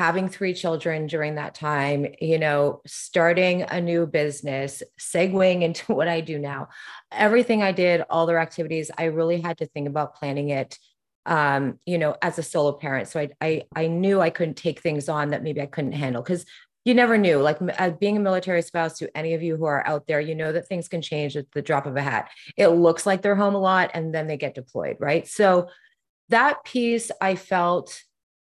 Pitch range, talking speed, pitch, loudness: 150-180 Hz, 215 wpm, 165 Hz, -23 LUFS